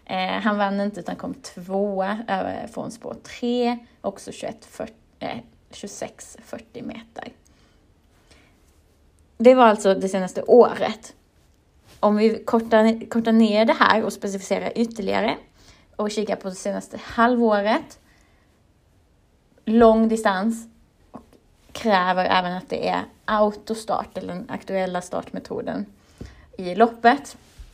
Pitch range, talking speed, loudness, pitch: 195-230 Hz, 110 wpm, -21 LUFS, 215 Hz